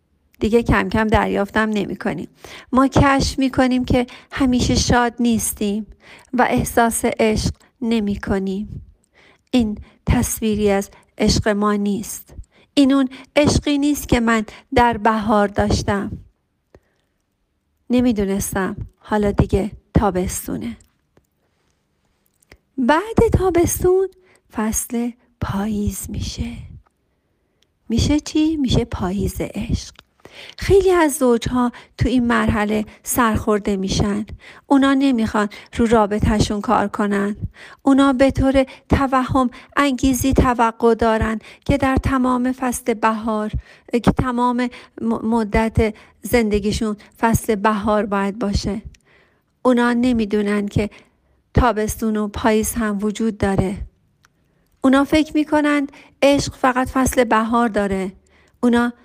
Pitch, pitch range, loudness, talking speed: 230 Hz, 210-260 Hz, -19 LUFS, 100 wpm